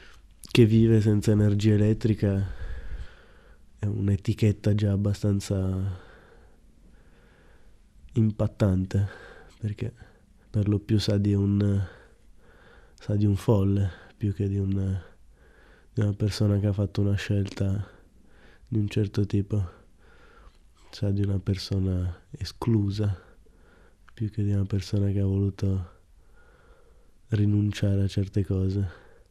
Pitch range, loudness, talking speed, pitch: 95-105 Hz, -26 LUFS, 110 wpm, 100 Hz